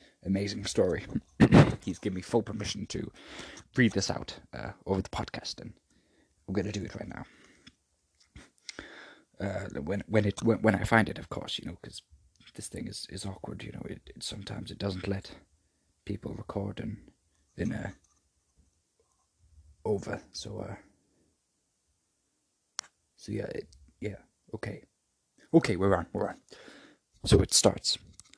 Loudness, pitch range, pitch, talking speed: -31 LUFS, 85-105 Hz, 100 Hz, 150 wpm